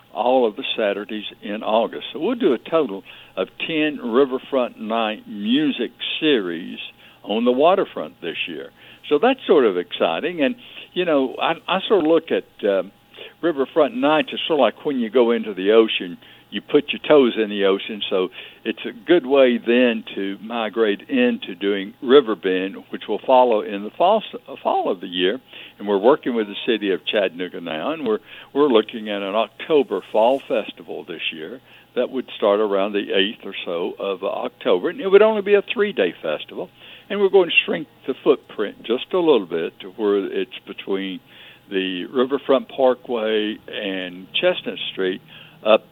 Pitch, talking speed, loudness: 125 Hz, 180 wpm, -20 LUFS